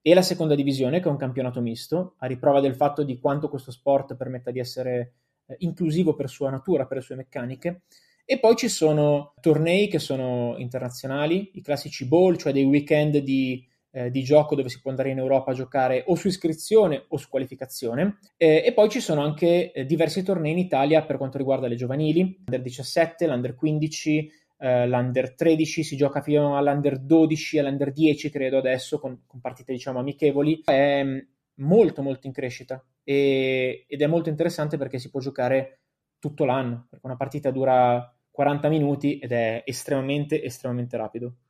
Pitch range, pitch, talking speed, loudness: 130-155 Hz, 140 Hz, 180 wpm, -24 LUFS